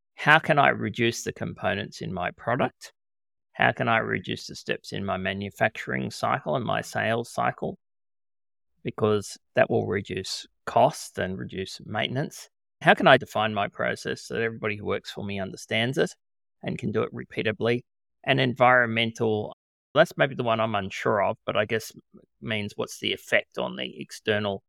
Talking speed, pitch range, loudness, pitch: 170 wpm, 100-115 Hz, -26 LUFS, 105 Hz